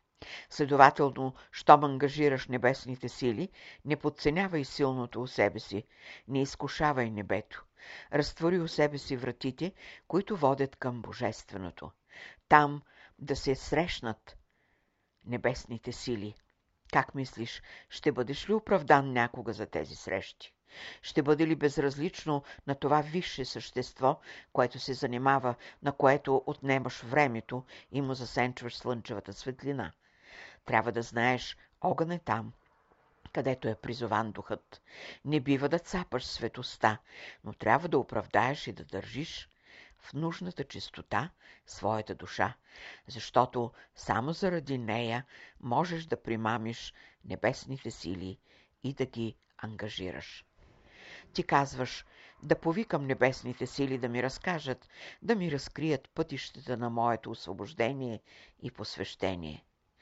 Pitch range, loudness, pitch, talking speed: 115-145 Hz, -32 LUFS, 130 Hz, 115 wpm